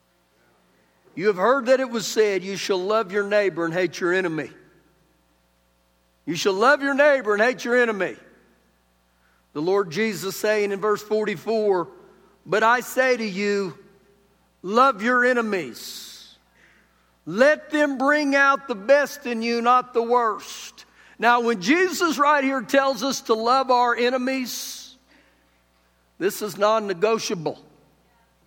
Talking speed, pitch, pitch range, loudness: 140 wpm, 215 Hz, 180-250 Hz, -21 LUFS